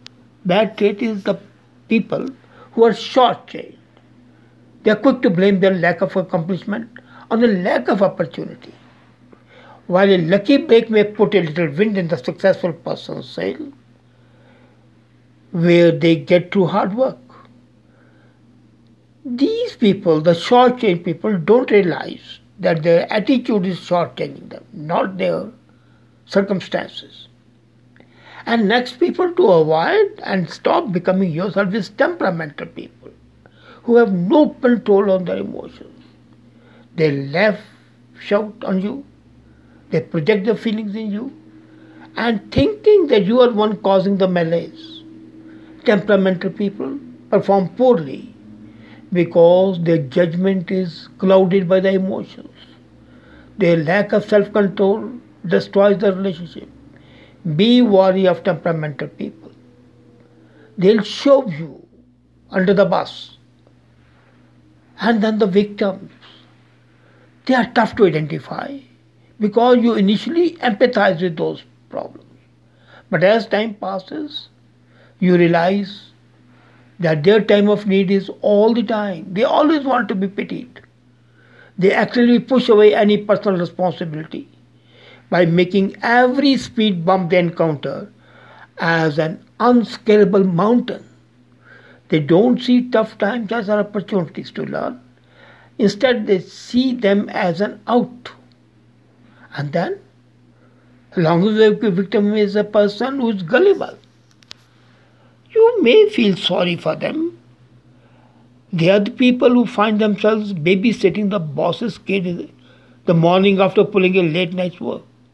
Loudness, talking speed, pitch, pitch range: -16 LUFS, 125 wpm, 200 Hz, 175-225 Hz